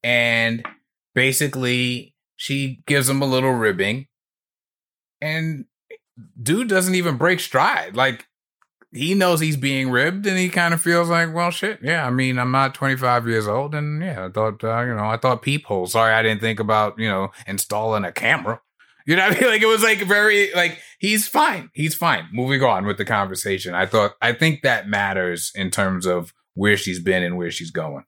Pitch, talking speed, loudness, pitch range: 130 Hz, 195 wpm, -20 LUFS, 110-170 Hz